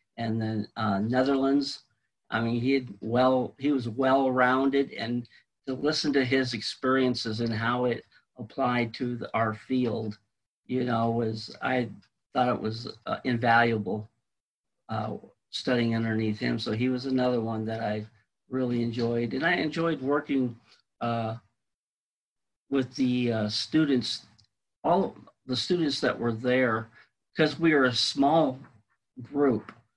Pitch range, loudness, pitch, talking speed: 115-130 Hz, -28 LUFS, 120 Hz, 140 wpm